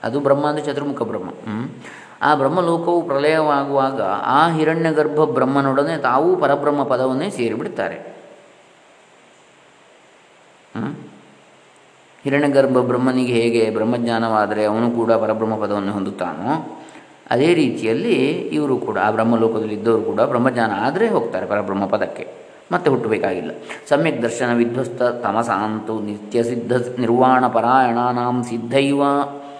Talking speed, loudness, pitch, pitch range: 100 wpm, -19 LUFS, 125 Hz, 115-140 Hz